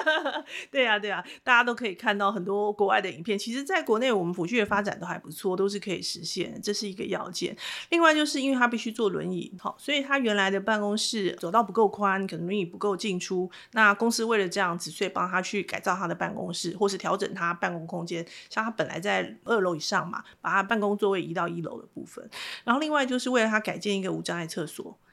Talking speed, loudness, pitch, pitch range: 365 characters per minute, -27 LUFS, 200 Hz, 185-230 Hz